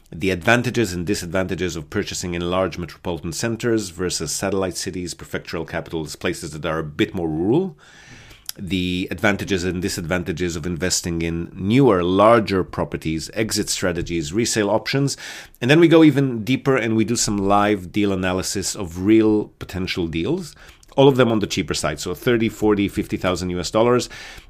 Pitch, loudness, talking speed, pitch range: 95 Hz, -20 LUFS, 160 wpm, 90-110 Hz